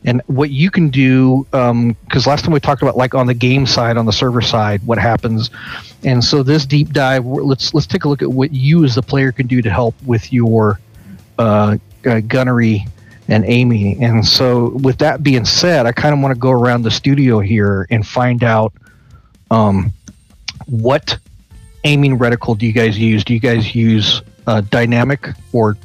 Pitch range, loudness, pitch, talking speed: 110-135 Hz, -13 LUFS, 120 Hz, 195 wpm